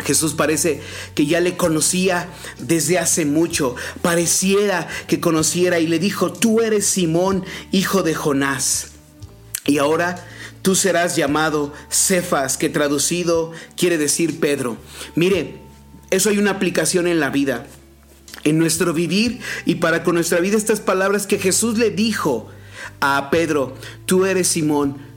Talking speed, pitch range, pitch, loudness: 140 wpm, 145-185 Hz, 170 Hz, -18 LUFS